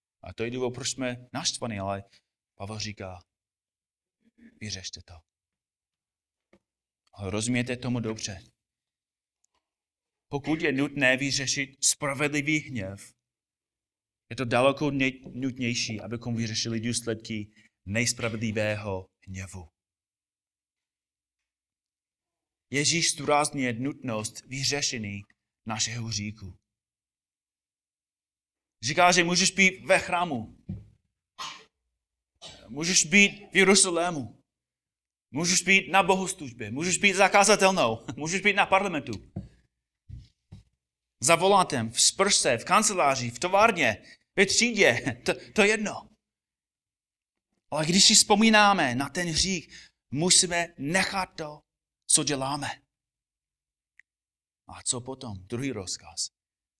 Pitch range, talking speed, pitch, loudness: 105-165 Hz, 95 wpm, 125 Hz, -24 LUFS